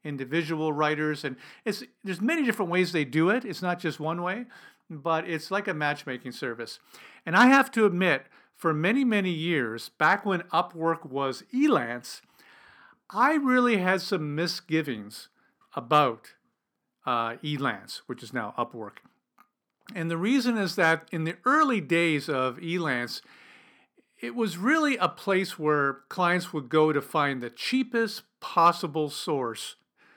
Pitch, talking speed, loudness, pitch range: 170 Hz, 145 wpm, -26 LUFS, 155-205 Hz